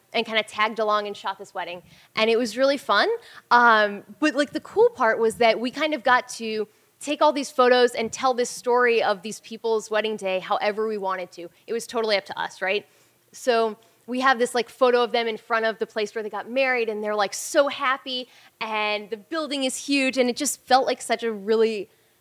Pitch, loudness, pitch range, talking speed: 225 Hz, -23 LUFS, 210-255 Hz, 230 wpm